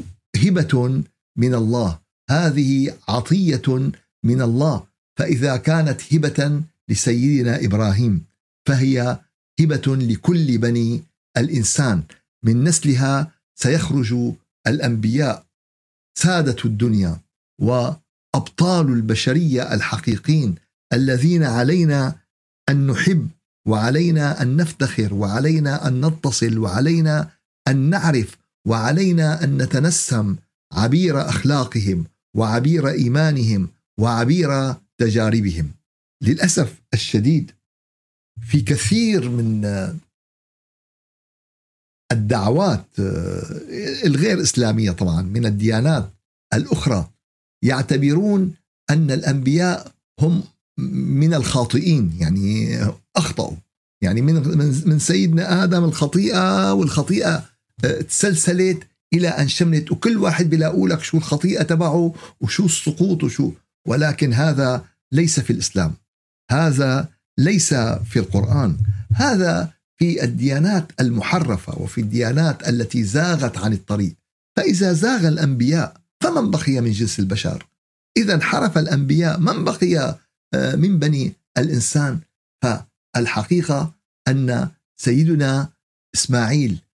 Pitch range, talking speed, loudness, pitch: 115-160 Hz, 90 wpm, -19 LUFS, 135 Hz